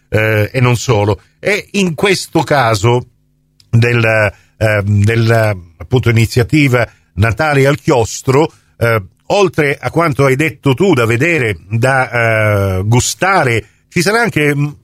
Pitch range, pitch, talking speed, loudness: 110-145 Hz, 120 Hz, 120 wpm, -13 LUFS